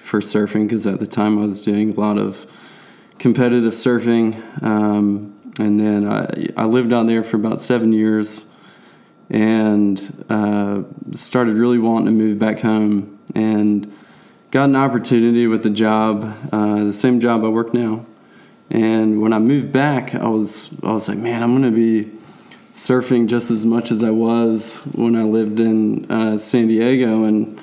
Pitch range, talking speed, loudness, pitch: 105-120 Hz, 170 wpm, -17 LUFS, 110 Hz